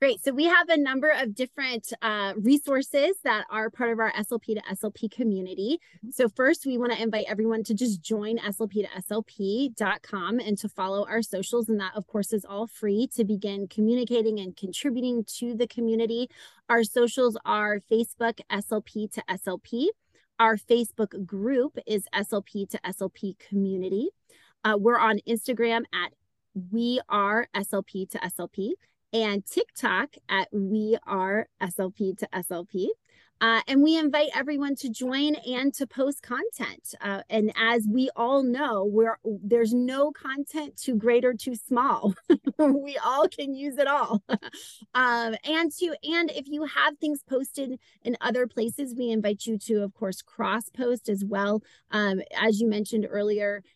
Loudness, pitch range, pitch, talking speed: -27 LUFS, 210-255 Hz, 225 Hz, 160 wpm